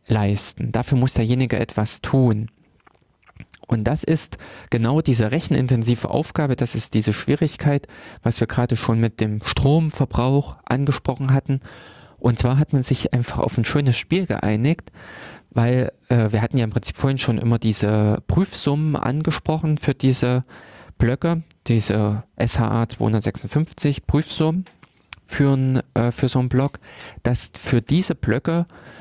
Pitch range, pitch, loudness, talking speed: 115-145 Hz, 125 Hz, -21 LUFS, 140 wpm